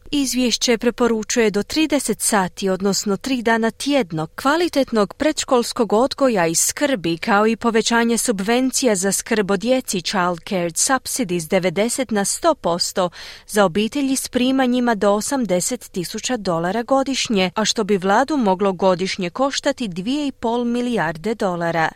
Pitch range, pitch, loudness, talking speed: 195-255 Hz, 225 Hz, -19 LUFS, 130 wpm